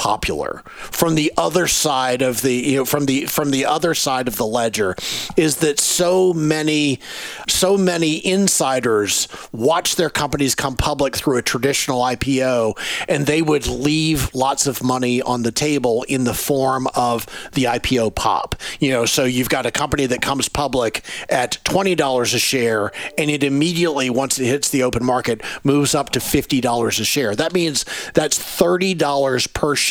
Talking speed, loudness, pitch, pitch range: 180 wpm, -18 LUFS, 140 Hz, 125-155 Hz